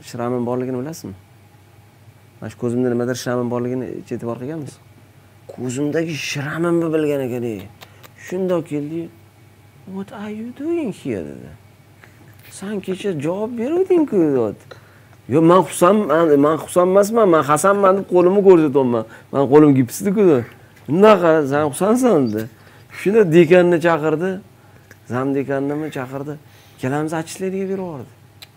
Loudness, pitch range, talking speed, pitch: -17 LUFS, 120-180 Hz, 115 wpm, 145 Hz